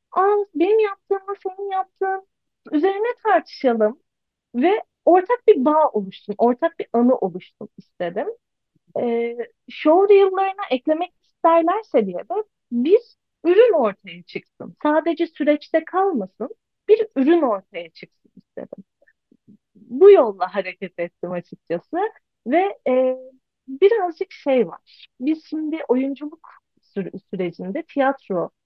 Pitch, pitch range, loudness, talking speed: 310 Hz, 230-385 Hz, -20 LUFS, 110 wpm